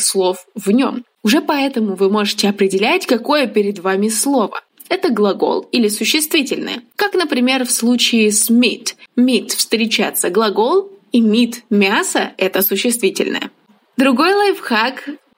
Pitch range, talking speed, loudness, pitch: 210-280 Hz, 130 wpm, -15 LUFS, 240 Hz